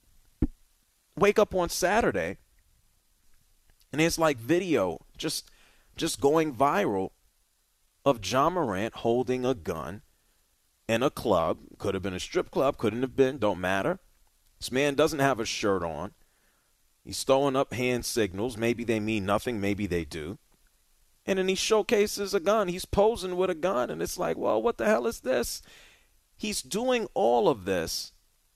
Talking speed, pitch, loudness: 160 wpm, 135 Hz, -28 LUFS